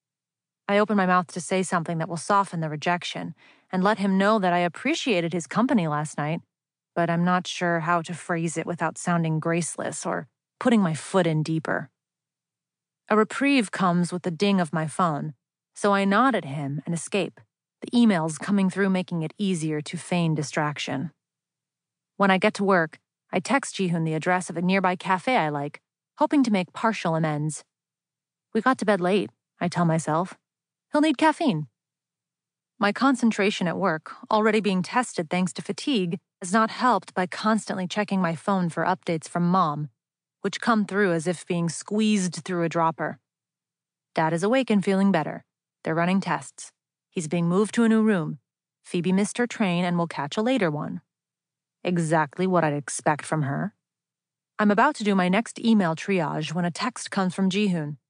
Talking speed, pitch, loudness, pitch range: 180 wpm, 180 Hz, -24 LUFS, 165-205 Hz